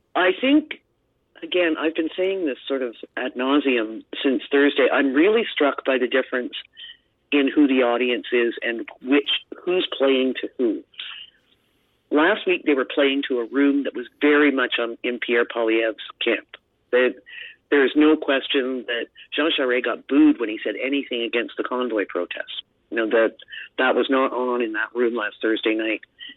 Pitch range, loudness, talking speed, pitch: 120-165 Hz, -21 LUFS, 175 wpm, 135 Hz